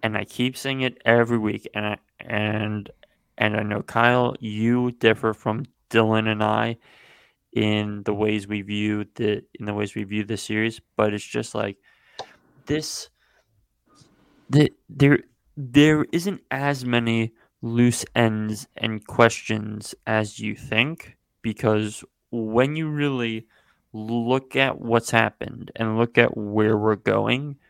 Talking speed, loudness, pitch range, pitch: 140 wpm, -23 LUFS, 105-125 Hz, 110 Hz